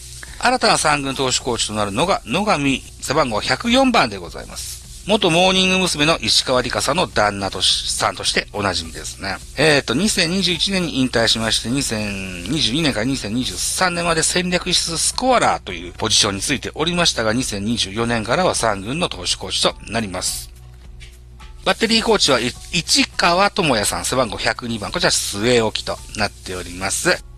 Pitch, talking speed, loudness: 120 Hz, 335 characters per minute, -18 LUFS